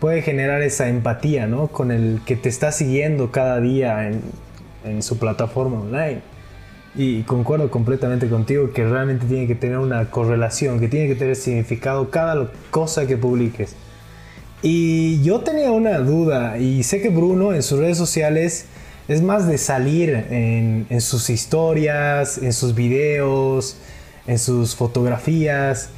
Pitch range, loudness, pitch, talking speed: 120-150 Hz, -19 LUFS, 130 Hz, 150 wpm